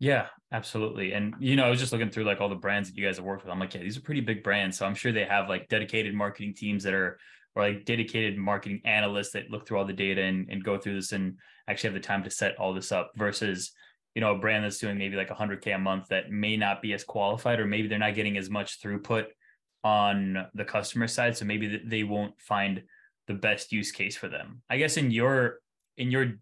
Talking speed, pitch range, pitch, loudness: 255 wpm, 100-110 Hz, 105 Hz, -29 LUFS